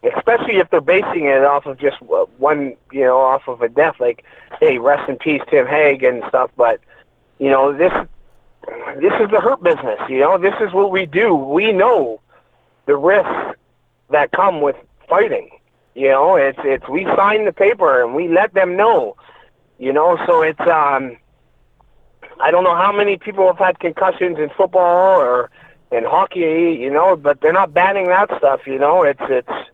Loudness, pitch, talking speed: -15 LUFS, 185 Hz, 185 wpm